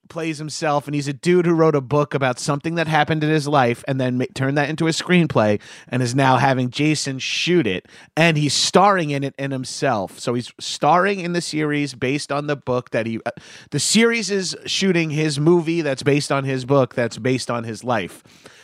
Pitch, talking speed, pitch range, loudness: 145 Hz, 220 wpm, 130-165 Hz, -20 LUFS